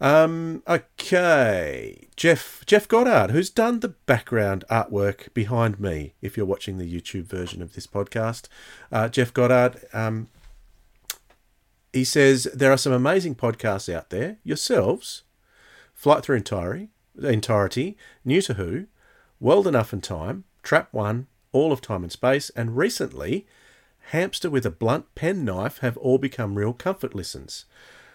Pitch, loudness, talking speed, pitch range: 120 Hz, -23 LUFS, 145 wpm, 100-140 Hz